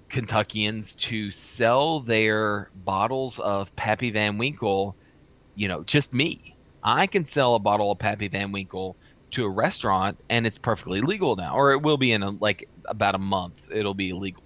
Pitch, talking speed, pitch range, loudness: 105 Hz, 180 wpm, 100-115 Hz, -25 LUFS